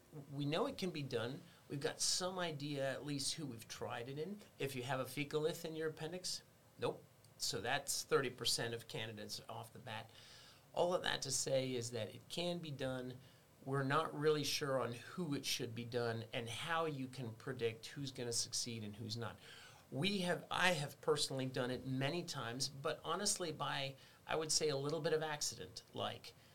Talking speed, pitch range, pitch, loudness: 200 wpm, 120-155 Hz, 135 Hz, -41 LUFS